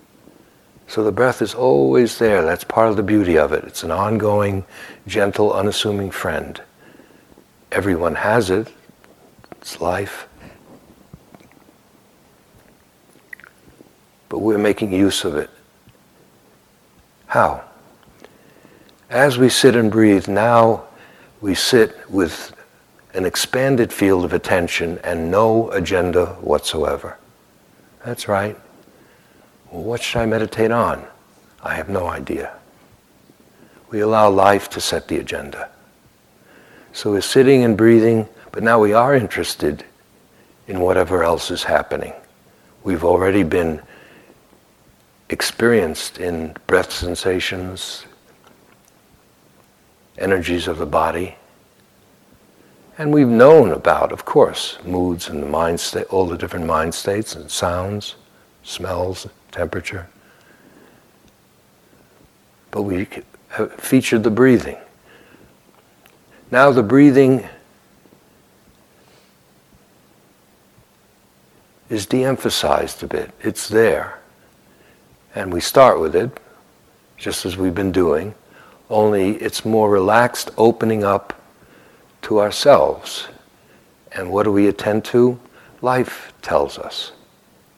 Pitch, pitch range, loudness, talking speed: 105 Hz, 90-115 Hz, -17 LUFS, 105 wpm